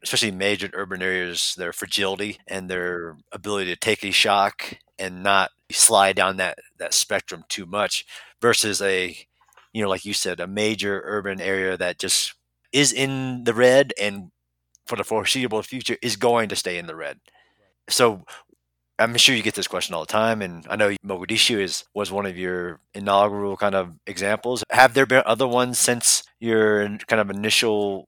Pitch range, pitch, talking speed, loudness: 95-115 Hz, 100 Hz, 180 wpm, -21 LUFS